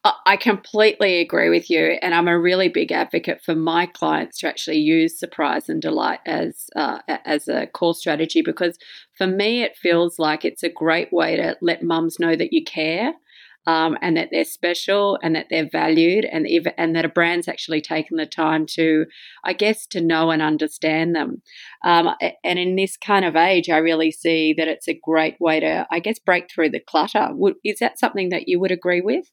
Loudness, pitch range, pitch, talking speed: -20 LUFS, 160-195 Hz, 170 Hz, 205 wpm